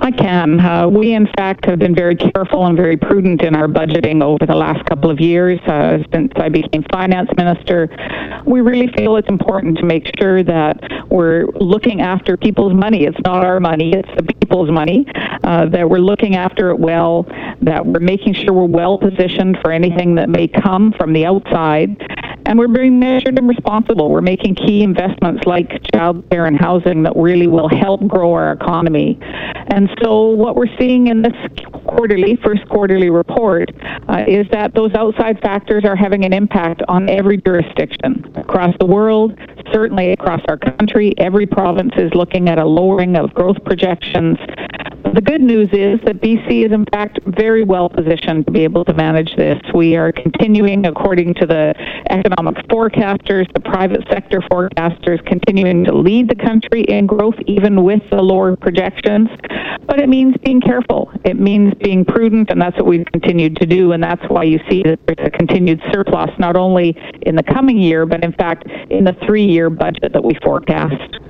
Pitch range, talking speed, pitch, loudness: 170-210 Hz, 185 wpm, 190 Hz, -13 LUFS